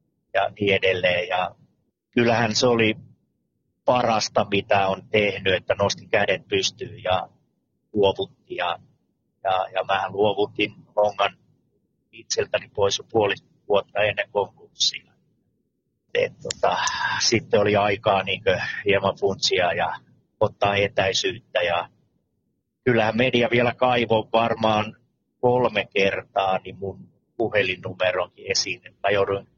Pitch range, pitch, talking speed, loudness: 100-120 Hz, 105 Hz, 110 wpm, -23 LUFS